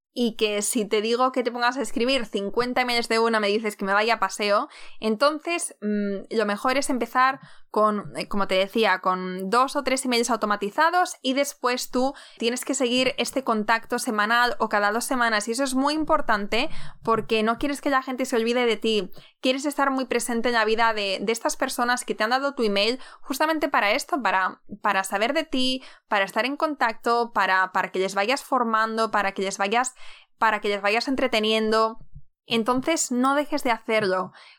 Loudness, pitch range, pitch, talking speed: -24 LUFS, 210-260 Hz, 230 Hz, 200 wpm